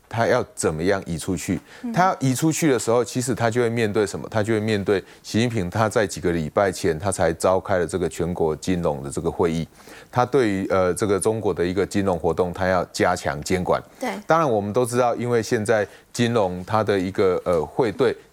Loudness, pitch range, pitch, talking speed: -22 LUFS, 95-125 Hz, 110 Hz, 320 characters per minute